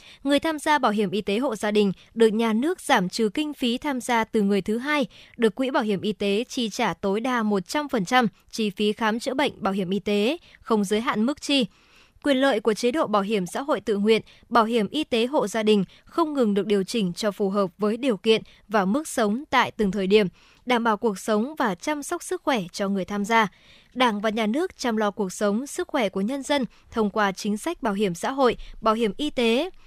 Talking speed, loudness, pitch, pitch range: 245 wpm, -24 LUFS, 225 Hz, 210-260 Hz